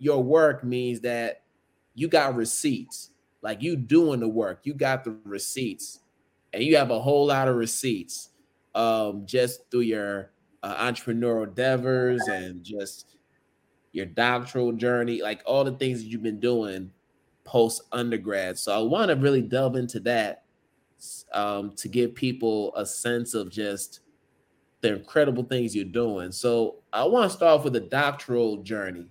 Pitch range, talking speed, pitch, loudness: 105-125 Hz, 160 wpm, 120 Hz, -25 LUFS